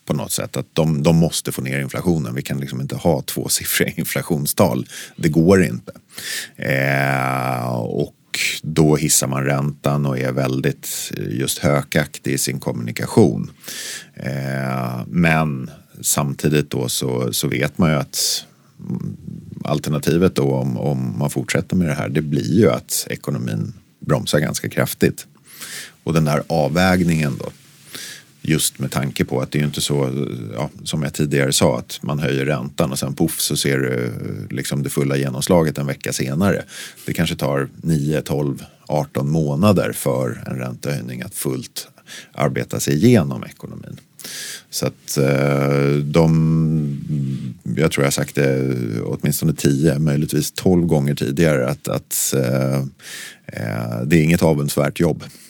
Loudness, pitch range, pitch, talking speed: -19 LUFS, 65-75 Hz, 70 Hz, 150 wpm